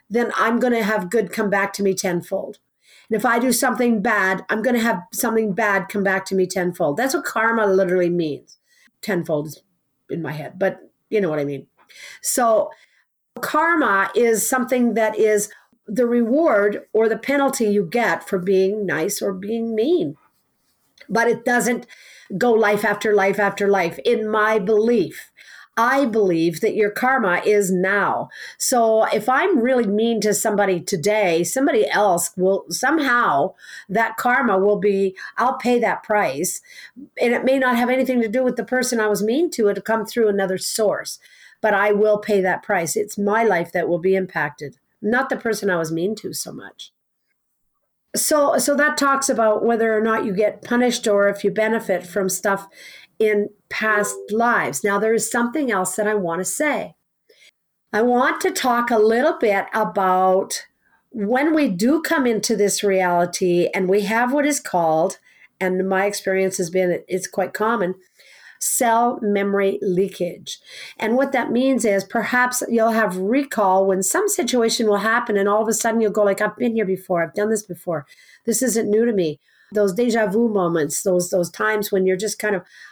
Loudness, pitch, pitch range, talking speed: -19 LUFS, 215 Hz, 195-240 Hz, 185 wpm